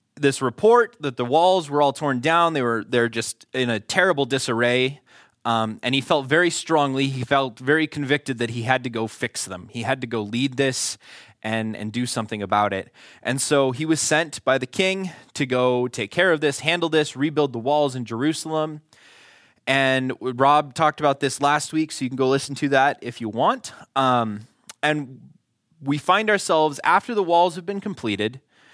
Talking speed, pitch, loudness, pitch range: 200 wpm, 135 Hz, -22 LUFS, 120-155 Hz